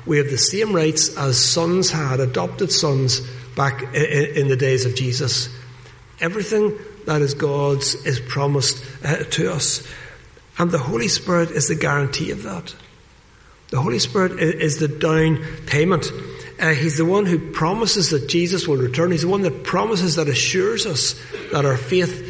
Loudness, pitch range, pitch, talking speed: -19 LUFS, 135-170 Hz, 150 Hz, 160 wpm